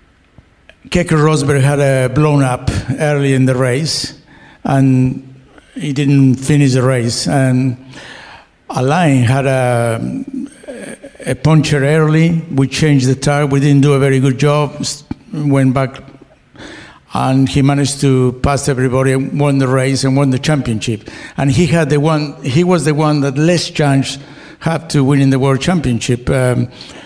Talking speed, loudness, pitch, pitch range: 155 wpm, -13 LUFS, 140 Hz, 130-150 Hz